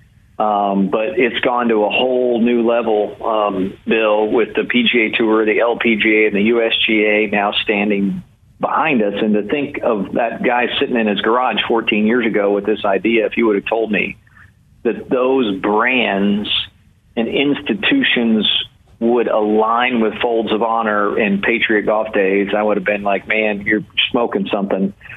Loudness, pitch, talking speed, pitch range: -16 LUFS, 110 Hz, 165 wpm, 105-115 Hz